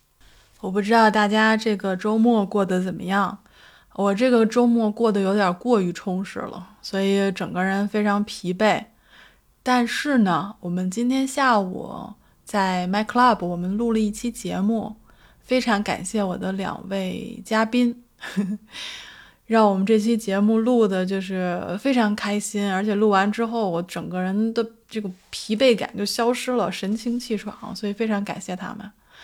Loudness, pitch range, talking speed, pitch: -22 LUFS, 195-225 Hz, 245 characters per minute, 210 Hz